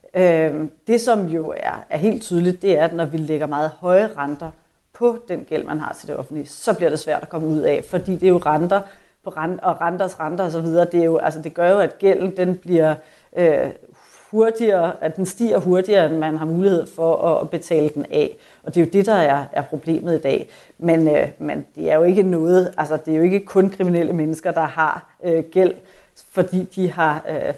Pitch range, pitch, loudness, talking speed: 160-185 Hz, 170 Hz, -19 LUFS, 225 wpm